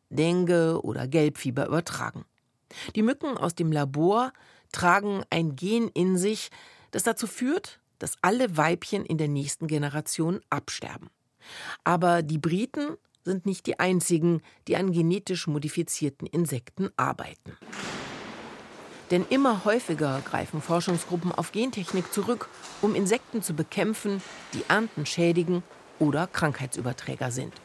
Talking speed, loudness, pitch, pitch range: 120 wpm, -27 LUFS, 175 Hz, 155-205 Hz